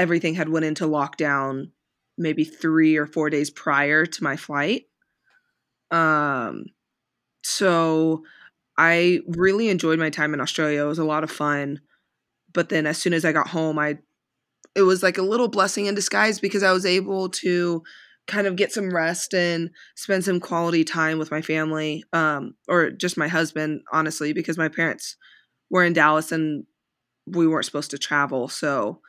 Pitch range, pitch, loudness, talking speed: 155-180 Hz, 160 Hz, -22 LUFS, 170 wpm